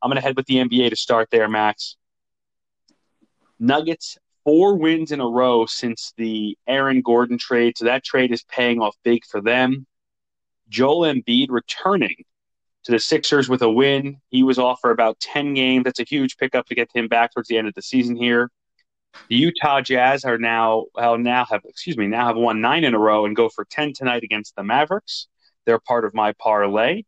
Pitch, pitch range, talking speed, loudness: 120 Hz, 115-135 Hz, 200 wpm, -19 LUFS